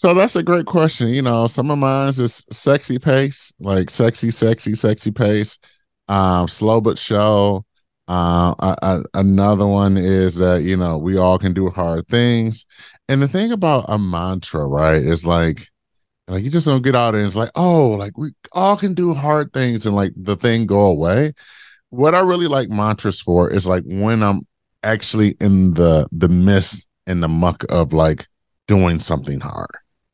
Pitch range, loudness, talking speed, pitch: 90-125 Hz, -17 LUFS, 185 wpm, 105 Hz